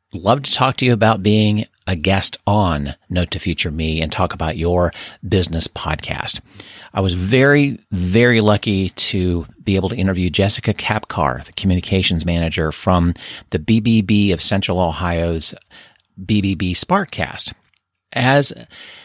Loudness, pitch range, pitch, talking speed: -17 LUFS, 85-105 Hz, 95 Hz, 140 wpm